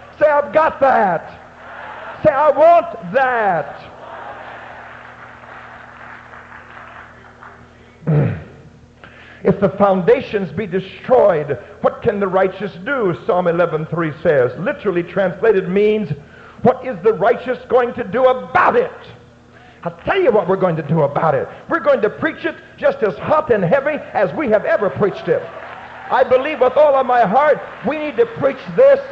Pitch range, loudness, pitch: 190-285 Hz, -16 LUFS, 245 Hz